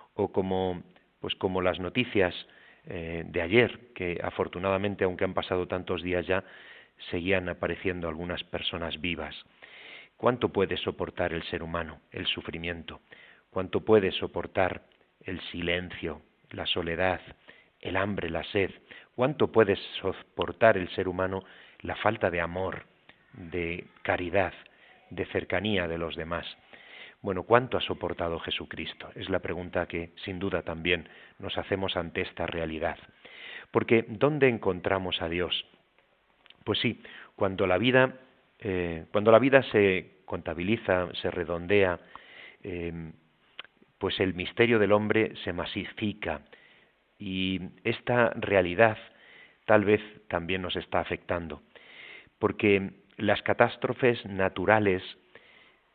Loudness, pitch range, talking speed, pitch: -29 LUFS, 85-105 Hz, 120 wpm, 90 Hz